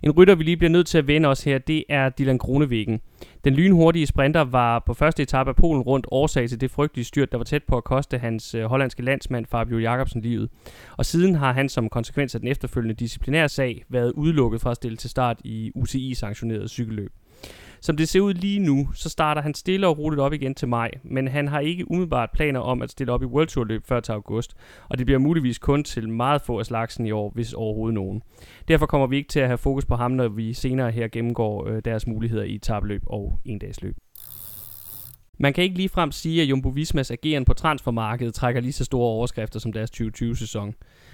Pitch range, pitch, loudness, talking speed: 115-145 Hz, 125 Hz, -23 LUFS, 225 wpm